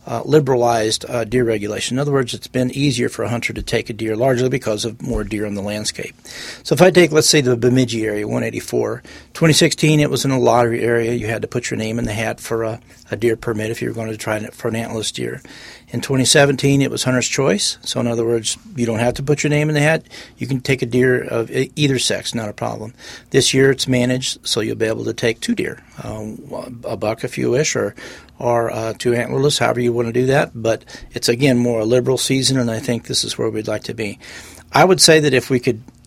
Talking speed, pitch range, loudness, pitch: 255 wpm, 115-135 Hz, -17 LUFS, 120 Hz